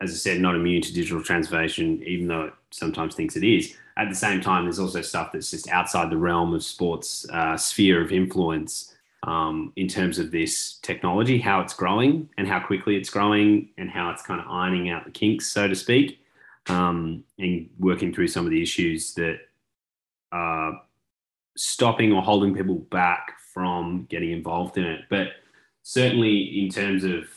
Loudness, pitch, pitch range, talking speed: -24 LUFS, 90 Hz, 85-100 Hz, 185 wpm